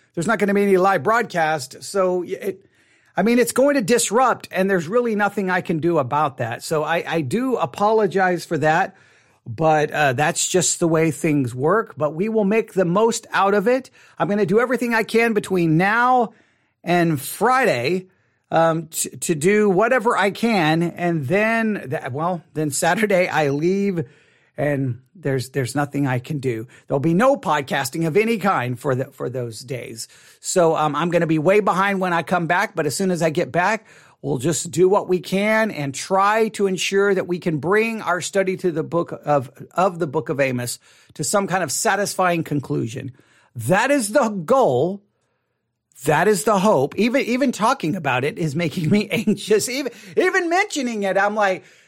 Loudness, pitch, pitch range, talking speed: -20 LUFS, 180 Hz, 155-210 Hz, 195 wpm